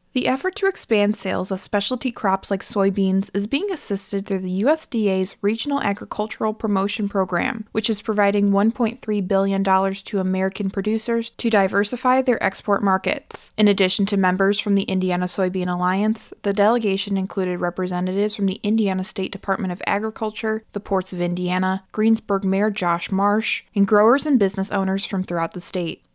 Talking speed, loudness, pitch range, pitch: 160 wpm, -21 LUFS, 190-220 Hz, 200 Hz